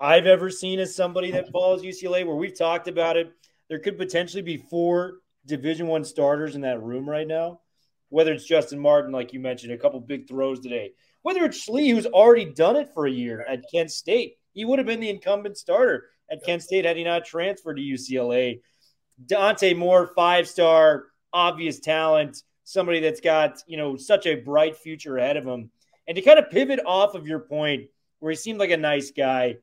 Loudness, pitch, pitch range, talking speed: -23 LUFS, 165 Hz, 145-185 Hz, 205 wpm